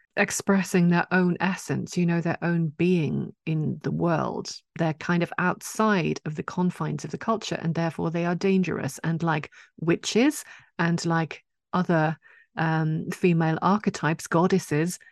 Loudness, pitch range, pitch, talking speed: -25 LUFS, 160-185 Hz, 170 Hz, 145 wpm